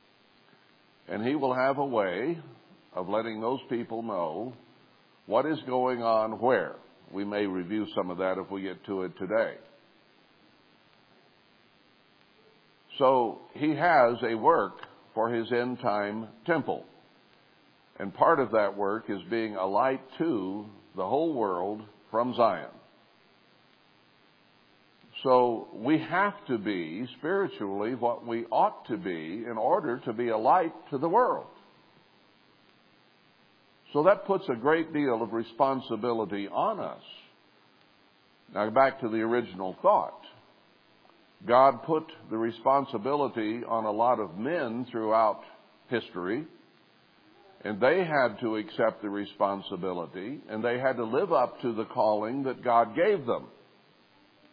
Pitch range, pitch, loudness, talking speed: 100-120 Hz, 110 Hz, -28 LUFS, 130 wpm